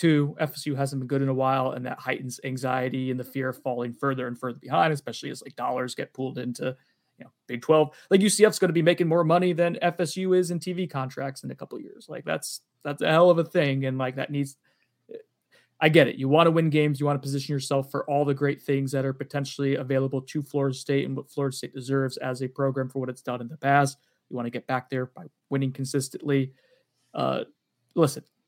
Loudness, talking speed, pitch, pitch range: -26 LUFS, 240 wpm, 140 Hz, 130-155 Hz